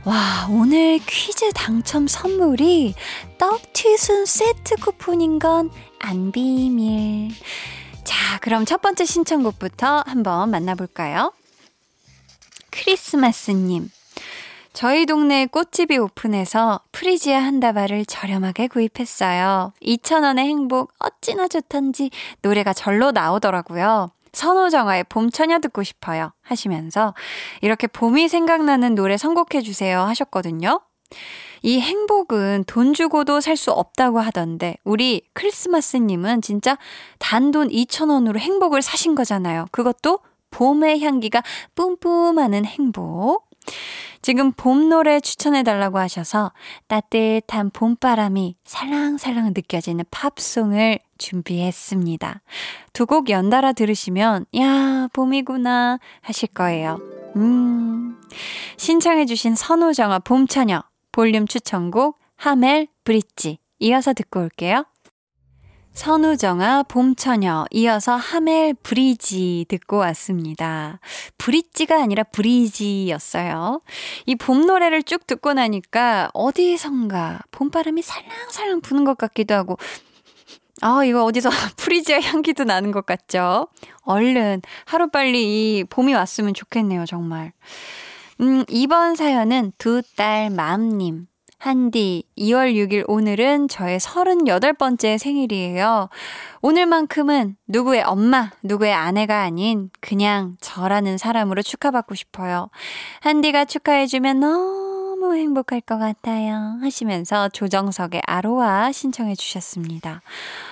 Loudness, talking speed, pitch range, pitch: -19 LUFS, 260 characters per minute, 200-290 Hz, 240 Hz